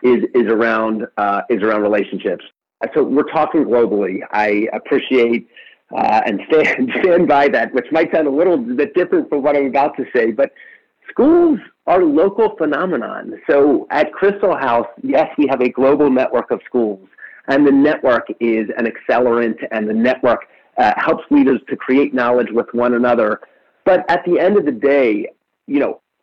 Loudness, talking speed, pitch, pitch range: -16 LUFS, 175 wpm, 125 Hz, 115-145 Hz